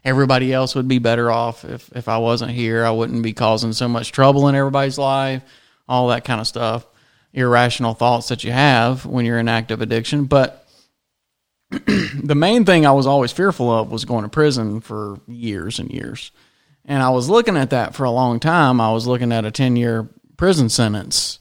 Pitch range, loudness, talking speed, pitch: 115-135 Hz, -17 LUFS, 200 wpm, 125 Hz